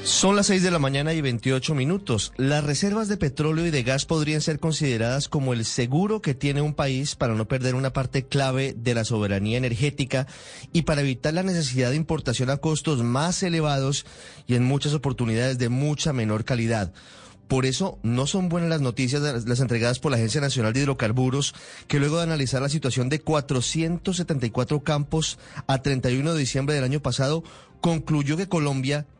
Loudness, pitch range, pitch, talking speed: -24 LUFS, 130-155 Hz, 140 Hz, 185 wpm